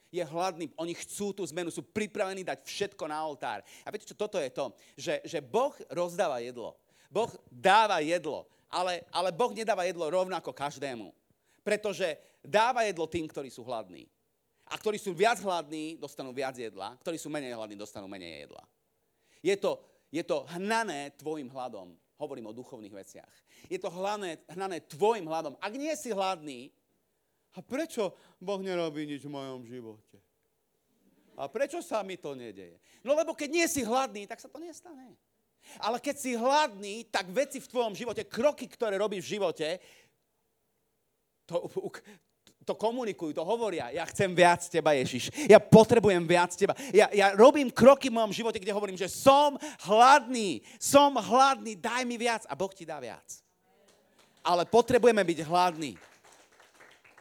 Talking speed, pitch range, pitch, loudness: 160 wpm, 160-235 Hz, 195 Hz, -28 LUFS